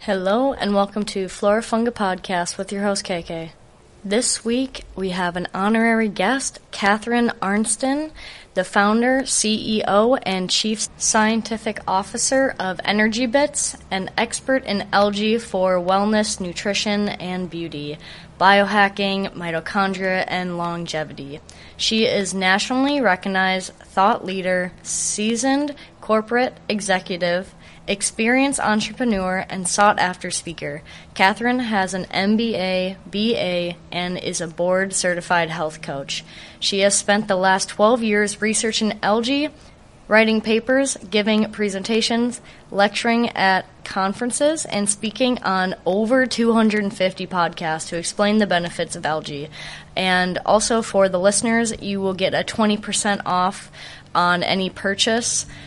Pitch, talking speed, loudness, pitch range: 200 Hz, 120 wpm, -20 LUFS, 185-220 Hz